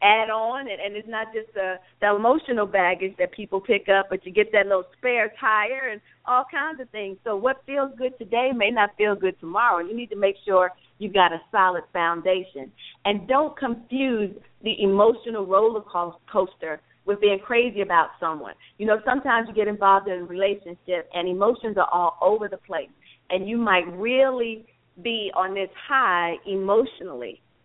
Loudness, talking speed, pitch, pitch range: -23 LUFS, 180 wpm, 205 Hz, 185-230 Hz